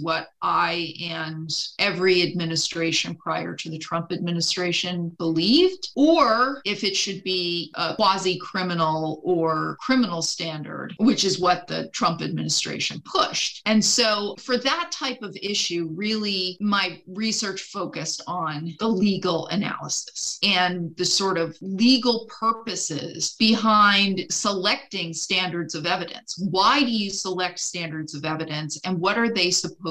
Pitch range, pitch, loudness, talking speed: 165-205 Hz, 185 Hz, -23 LUFS, 130 wpm